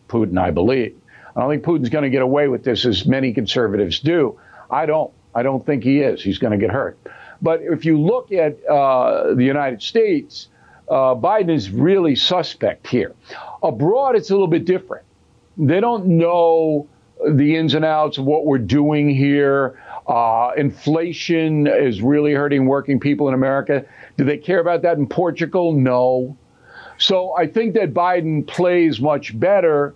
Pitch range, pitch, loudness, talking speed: 135-165 Hz, 145 Hz, -17 LUFS, 175 wpm